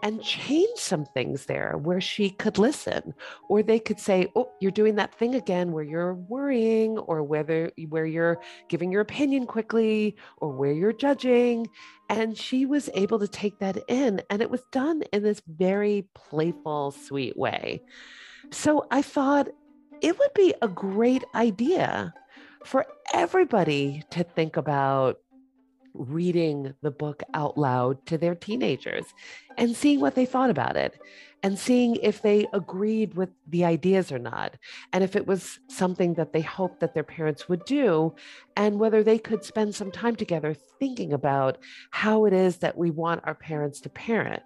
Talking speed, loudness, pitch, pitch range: 165 wpm, -26 LUFS, 205 Hz, 165-240 Hz